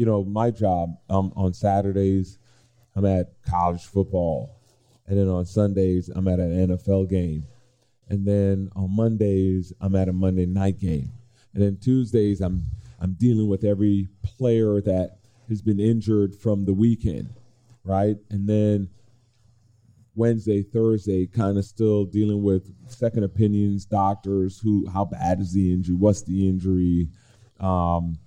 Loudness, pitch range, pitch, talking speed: -23 LUFS, 95-110 Hz, 100 Hz, 145 wpm